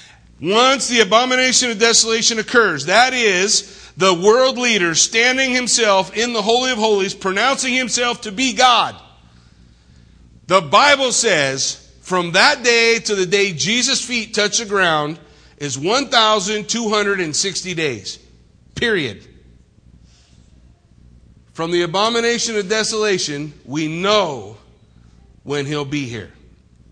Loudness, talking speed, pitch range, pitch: -15 LUFS, 115 wpm, 150-230 Hz, 205 Hz